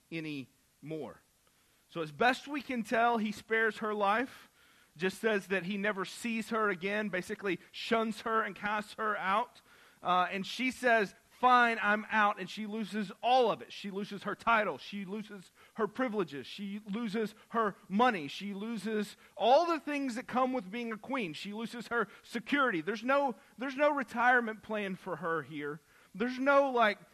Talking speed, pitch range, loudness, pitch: 175 wpm, 200-235 Hz, -32 LUFS, 215 Hz